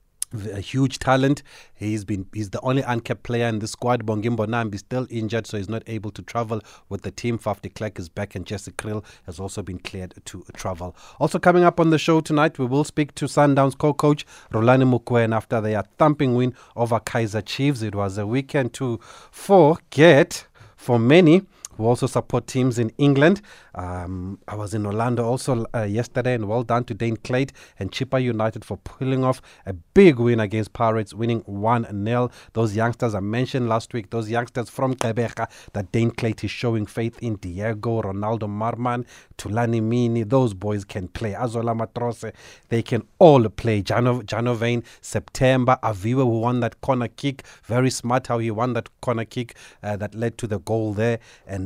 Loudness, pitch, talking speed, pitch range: -22 LUFS, 115 Hz, 185 wpm, 105-125 Hz